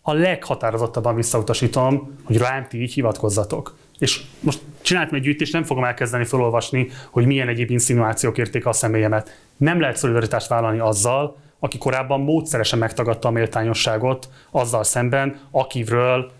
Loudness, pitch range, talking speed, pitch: -20 LUFS, 115-140 Hz, 140 wpm, 125 Hz